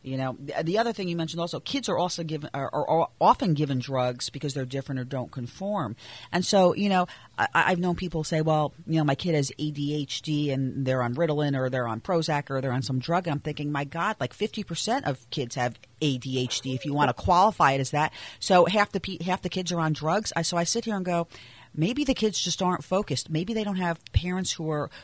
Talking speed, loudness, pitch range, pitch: 265 wpm, -27 LUFS, 135-180 Hz, 155 Hz